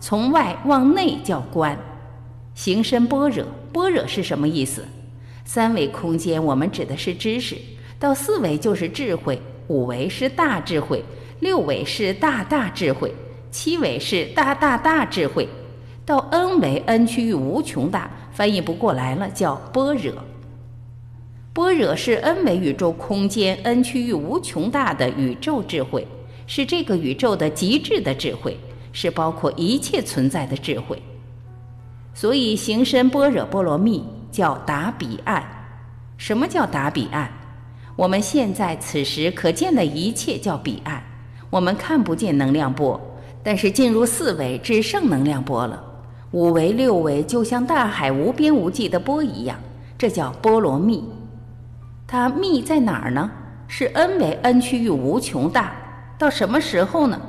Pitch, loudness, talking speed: 170 Hz, -21 LUFS, 220 characters per minute